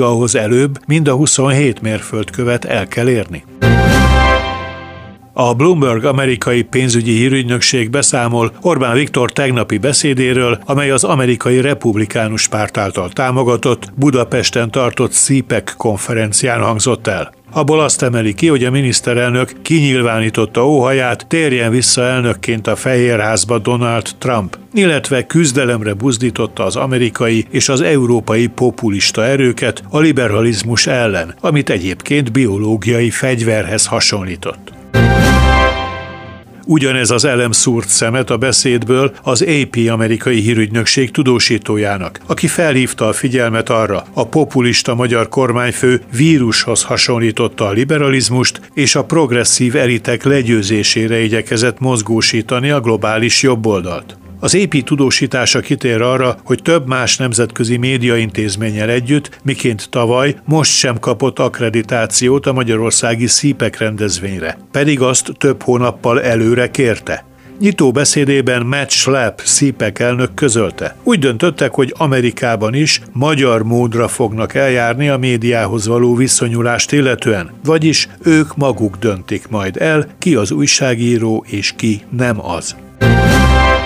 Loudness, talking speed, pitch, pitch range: -13 LUFS, 115 wpm, 120 Hz, 110-135 Hz